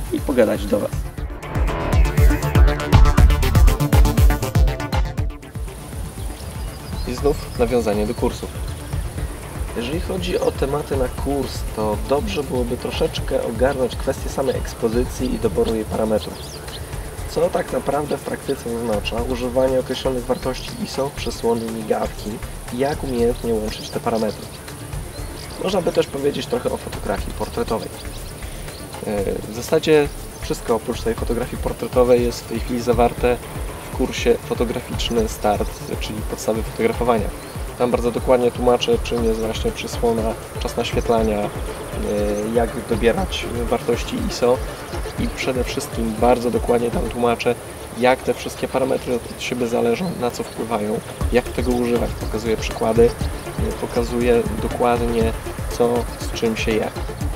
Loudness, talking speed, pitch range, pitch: -21 LUFS, 120 wpm, 105-125 Hz, 115 Hz